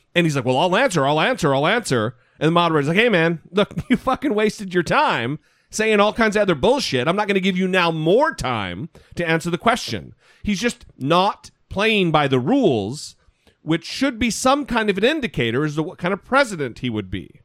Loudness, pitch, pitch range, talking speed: -19 LUFS, 180 Hz, 155-220 Hz, 225 wpm